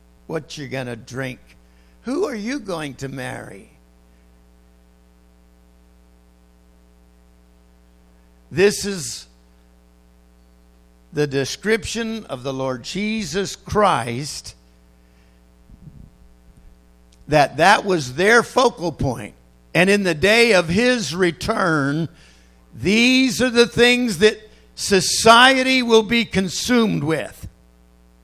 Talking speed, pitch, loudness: 90 wpm, 120 Hz, -18 LUFS